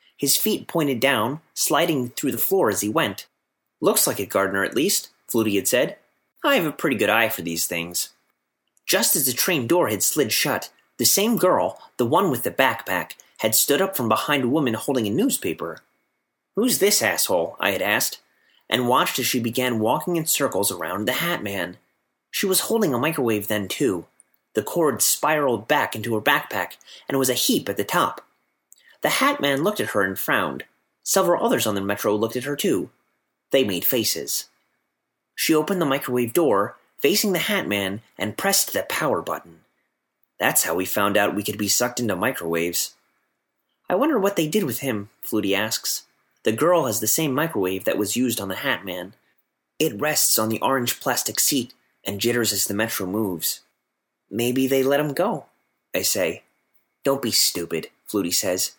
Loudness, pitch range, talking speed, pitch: -22 LUFS, 105-145 Hz, 190 wpm, 120 Hz